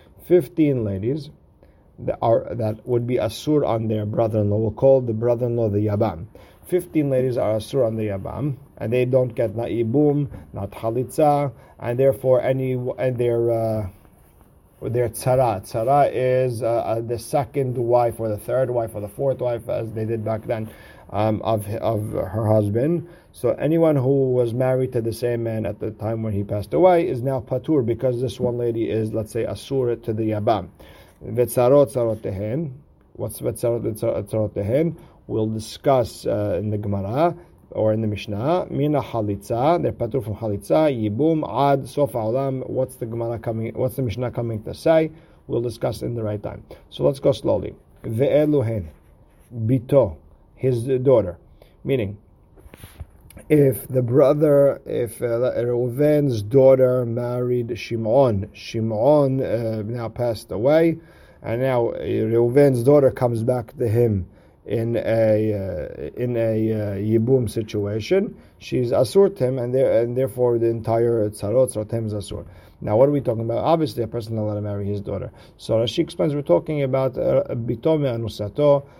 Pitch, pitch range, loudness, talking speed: 120 Hz, 110-130 Hz, -21 LUFS, 155 wpm